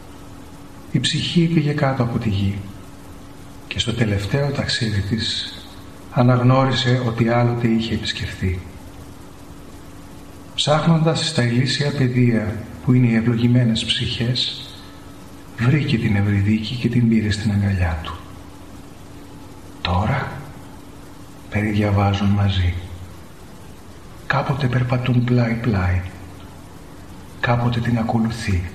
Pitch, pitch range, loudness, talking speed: 105 Hz, 95-120 Hz, -19 LUFS, 90 wpm